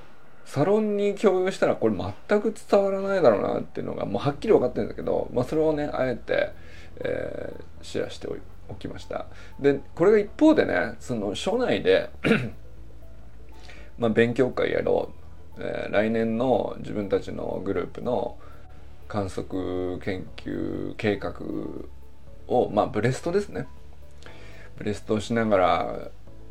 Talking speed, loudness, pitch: 280 characters per minute, -25 LUFS, 120 Hz